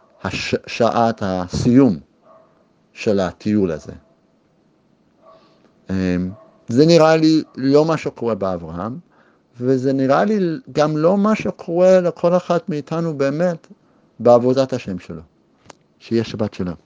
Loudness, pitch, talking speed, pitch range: -18 LUFS, 135 Hz, 105 wpm, 105-160 Hz